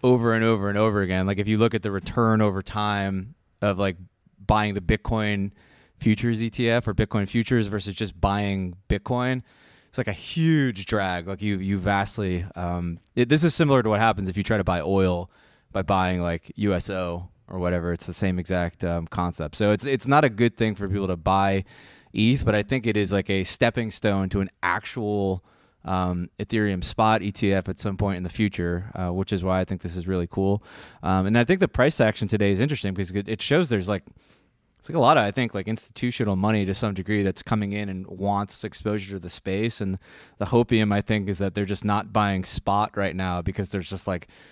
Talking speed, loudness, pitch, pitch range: 220 wpm, -24 LUFS, 100 Hz, 95-110 Hz